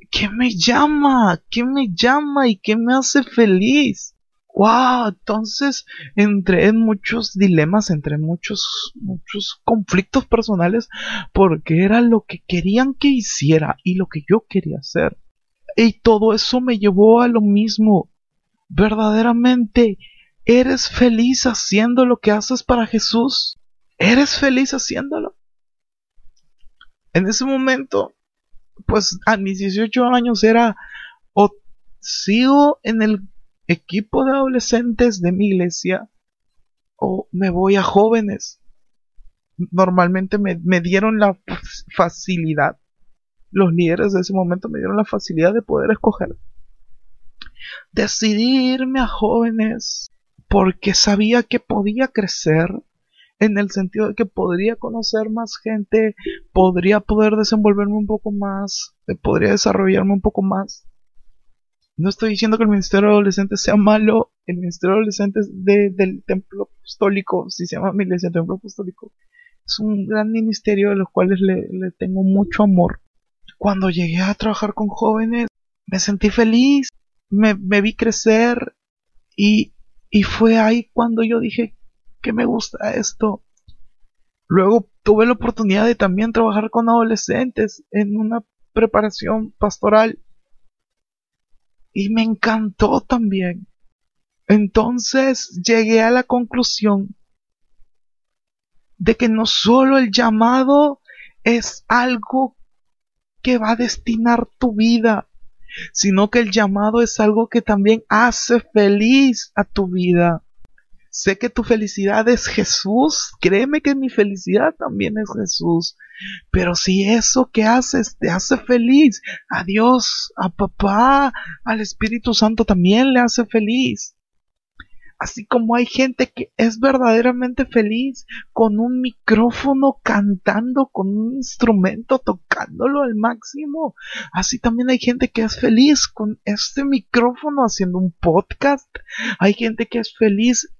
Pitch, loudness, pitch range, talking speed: 220 Hz, -17 LUFS, 200-240 Hz, 130 wpm